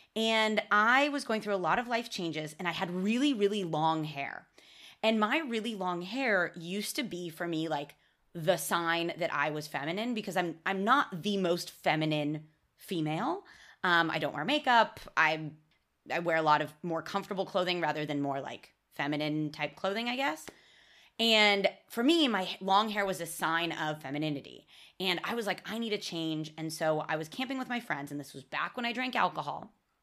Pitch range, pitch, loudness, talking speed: 155-215 Hz, 180 Hz, -31 LUFS, 200 wpm